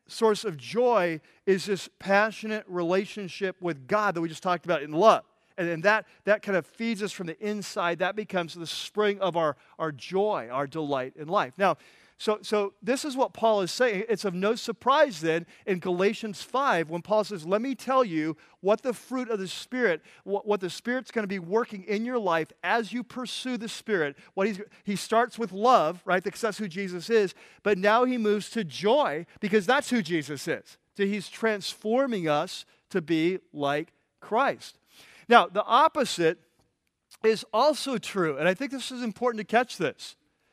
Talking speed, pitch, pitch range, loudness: 195 wpm, 205 Hz, 175-225 Hz, -27 LUFS